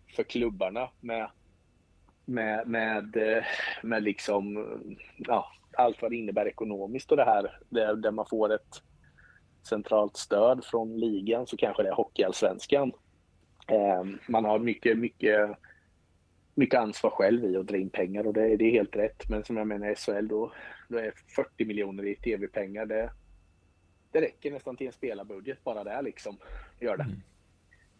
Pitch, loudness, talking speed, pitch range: 105 Hz, -29 LUFS, 160 wpm, 95-110 Hz